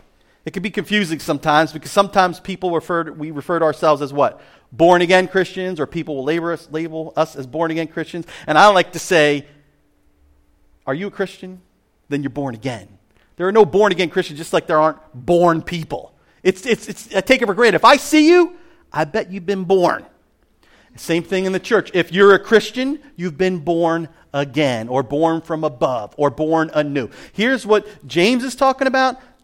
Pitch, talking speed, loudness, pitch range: 170 Hz, 200 wpm, -17 LUFS, 150-195 Hz